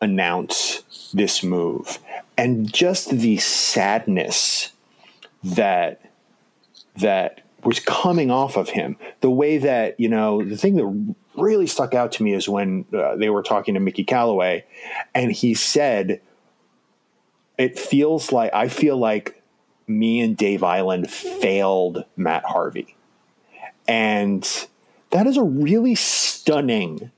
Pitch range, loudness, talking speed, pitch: 100-150 Hz, -20 LUFS, 130 wpm, 115 Hz